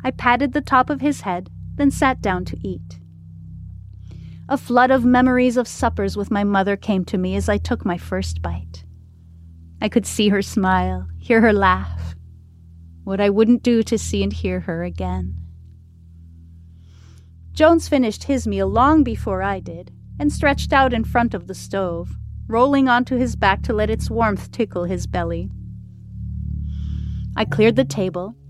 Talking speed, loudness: 165 wpm, -19 LUFS